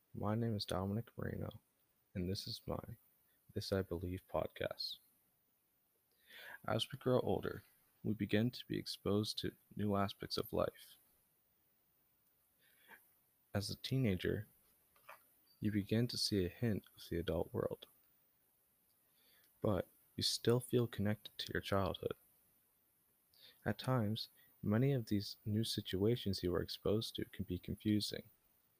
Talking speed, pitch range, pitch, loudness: 130 wpm, 100-115 Hz, 105 Hz, -40 LUFS